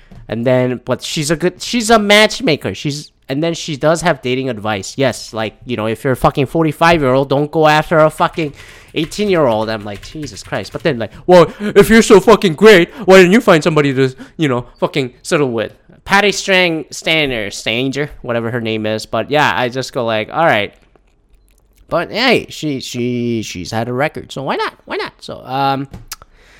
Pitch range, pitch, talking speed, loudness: 120-170 Hz, 140 Hz, 205 wpm, -14 LUFS